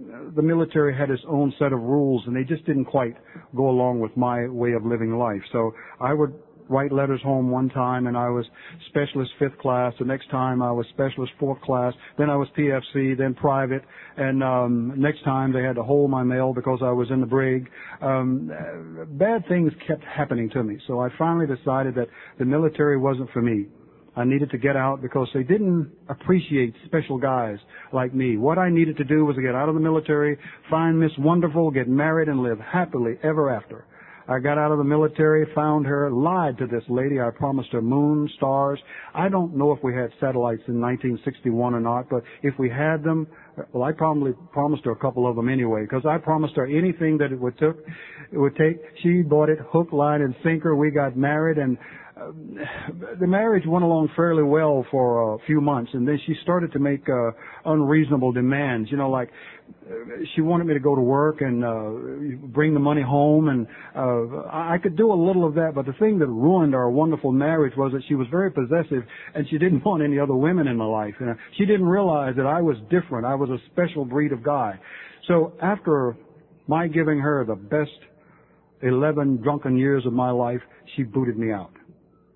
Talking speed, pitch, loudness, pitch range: 205 wpm, 140 Hz, -23 LUFS, 125-155 Hz